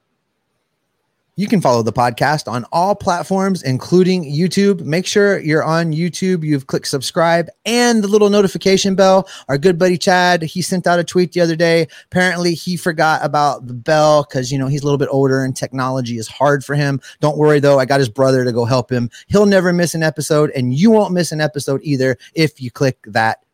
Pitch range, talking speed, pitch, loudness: 135-180 Hz, 210 wpm, 155 Hz, -15 LUFS